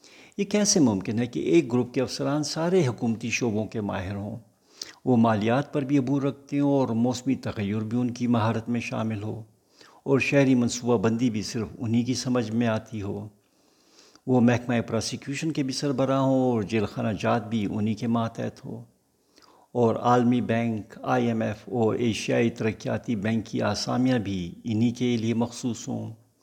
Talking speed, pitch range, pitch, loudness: 175 wpm, 110-125 Hz, 120 Hz, -26 LUFS